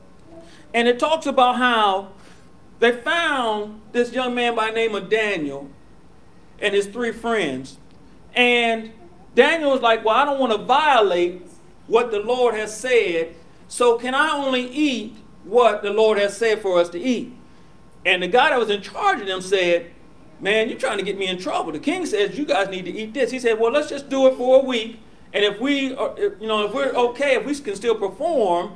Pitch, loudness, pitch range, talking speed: 230 Hz, -20 LUFS, 200-255 Hz, 205 wpm